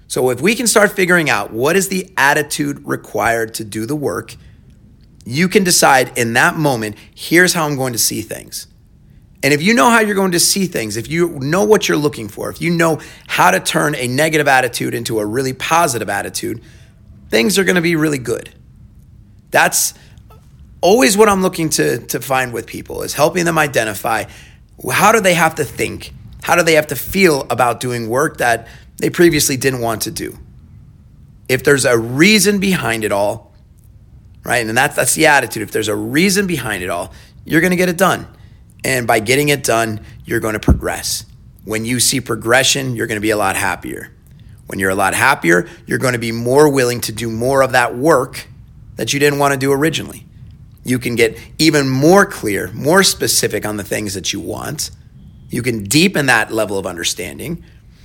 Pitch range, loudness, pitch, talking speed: 115-165 Hz, -15 LUFS, 135 Hz, 200 wpm